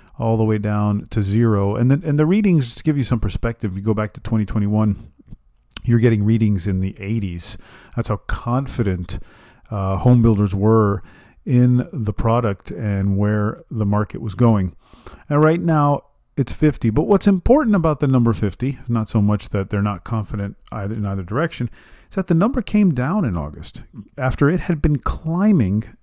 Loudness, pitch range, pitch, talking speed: -19 LUFS, 105-140 Hz, 115 Hz, 185 wpm